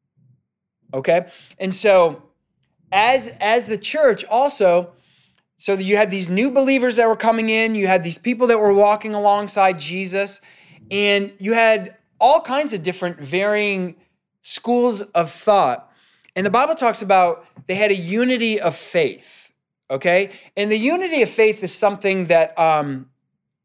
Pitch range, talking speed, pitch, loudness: 180-225 Hz, 150 wpm, 200 Hz, -18 LUFS